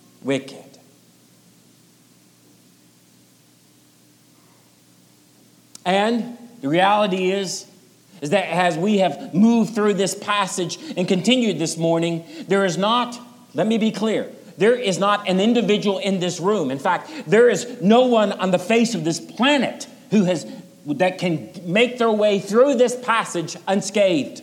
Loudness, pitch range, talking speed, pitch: -20 LUFS, 140-220 Hz, 140 wpm, 190 Hz